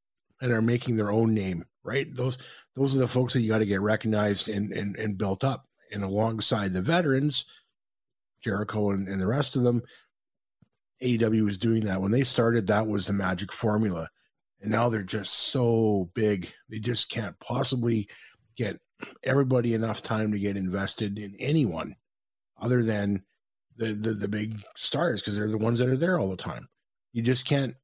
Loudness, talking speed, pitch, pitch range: -27 LUFS, 180 wpm, 110 Hz, 105-125 Hz